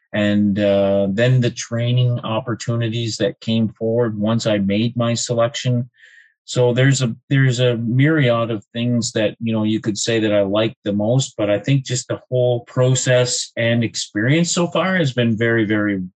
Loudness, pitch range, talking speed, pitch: -18 LUFS, 110-125 Hz, 180 wpm, 115 Hz